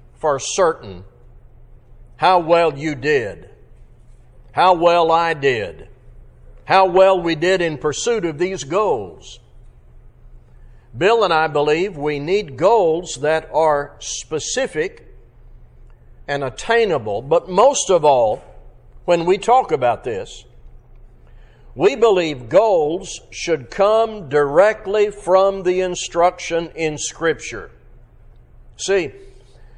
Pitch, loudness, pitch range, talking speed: 175 Hz, -17 LUFS, 150-200 Hz, 105 wpm